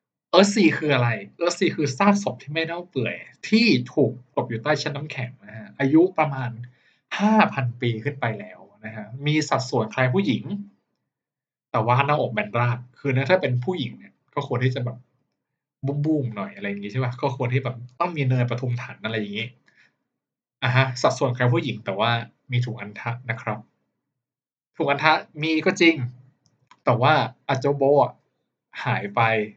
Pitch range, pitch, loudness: 120-150 Hz, 130 Hz, -23 LUFS